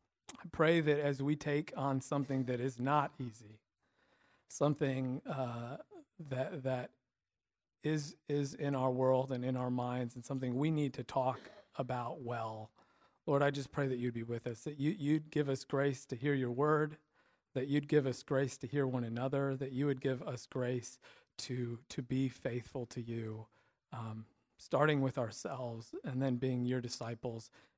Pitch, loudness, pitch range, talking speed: 130 Hz, -37 LUFS, 125-145 Hz, 175 wpm